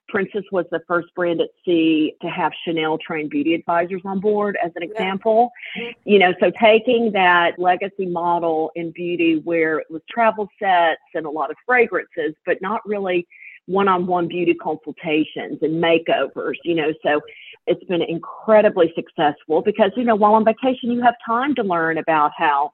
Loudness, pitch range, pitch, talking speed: -19 LUFS, 165-220 Hz, 180 Hz, 175 wpm